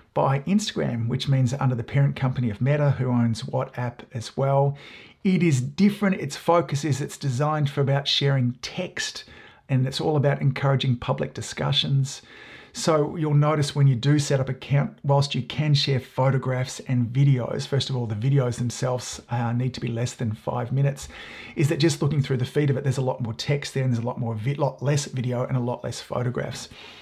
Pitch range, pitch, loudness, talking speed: 125-145 Hz, 135 Hz, -24 LUFS, 210 wpm